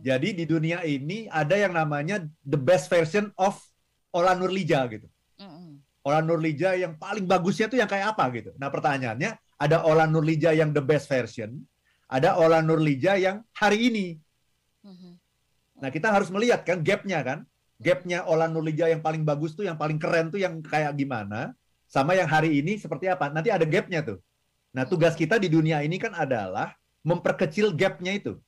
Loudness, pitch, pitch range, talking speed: -25 LUFS, 165 Hz, 150-185 Hz, 170 wpm